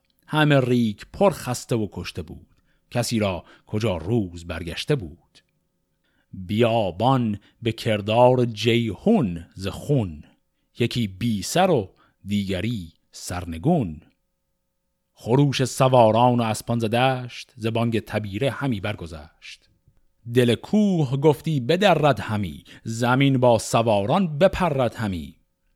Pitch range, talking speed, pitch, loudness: 100-130 Hz, 105 wpm, 115 Hz, -22 LUFS